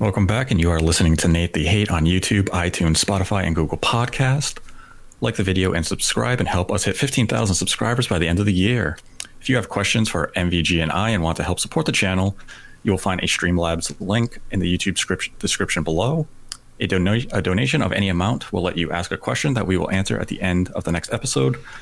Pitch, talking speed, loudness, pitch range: 95 Hz, 230 wpm, -20 LUFS, 85-110 Hz